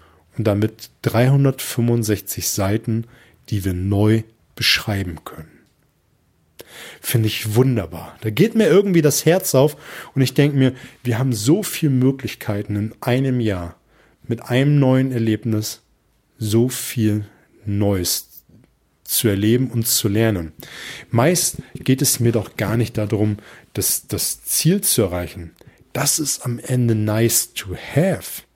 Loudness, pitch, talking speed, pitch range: -19 LUFS, 115 Hz, 130 wpm, 105-130 Hz